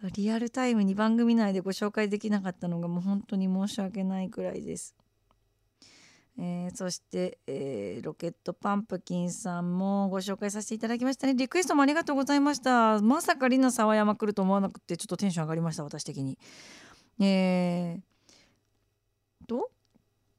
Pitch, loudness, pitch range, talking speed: 190 Hz, -29 LUFS, 170-215 Hz, 350 characters per minute